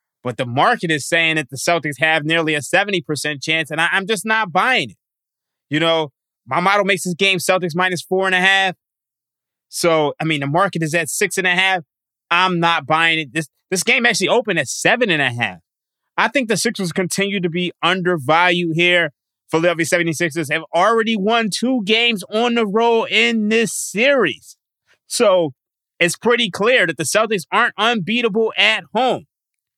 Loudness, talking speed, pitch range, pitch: -17 LUFS, 180 wpm, 160-220 Hz, 180 Hz